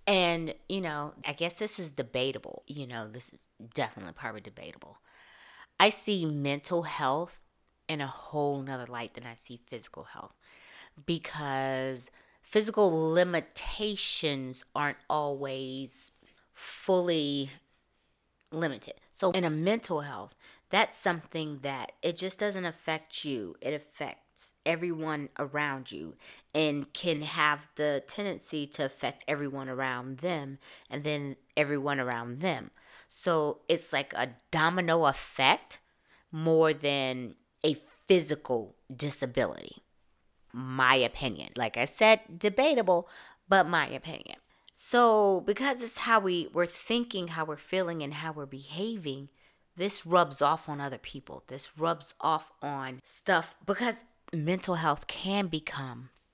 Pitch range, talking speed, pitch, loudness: 135-180 Hz, 125 wpm, 155 Hz, -30 LUFS